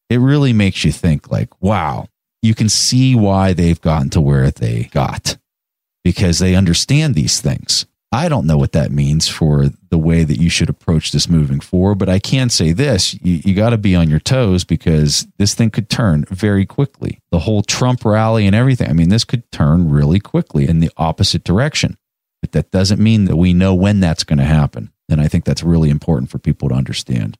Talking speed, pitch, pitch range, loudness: 210 wpm, 90 Hz, 80-105 Hz, -14 LUFS